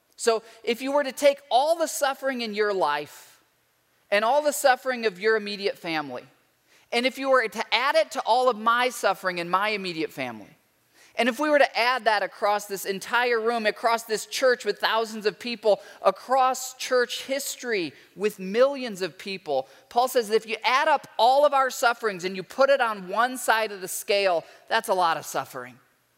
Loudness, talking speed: -24 LUFS, 200 wpm